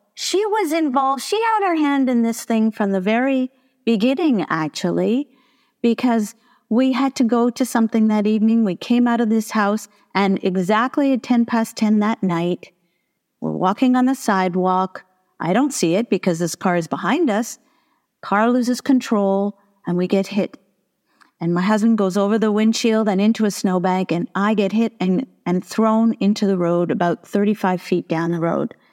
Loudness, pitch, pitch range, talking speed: -19 LUFS, 215 Hz, 190-250 Hz, 180 wpm